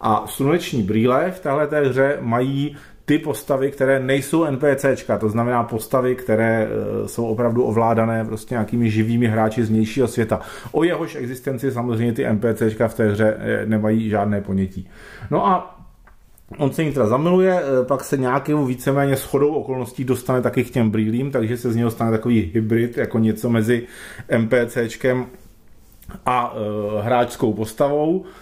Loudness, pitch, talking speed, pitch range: -20 LUFS, 120 Hz, 150 wpm, 110-135 Hz